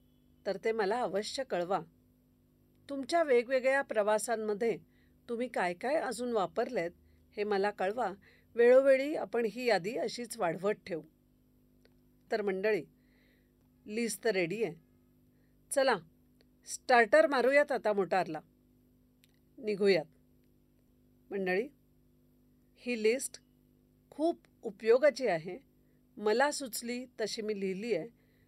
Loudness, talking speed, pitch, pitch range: -32 LUFS, 100 wpm, 220 Hz, 195-250 Hz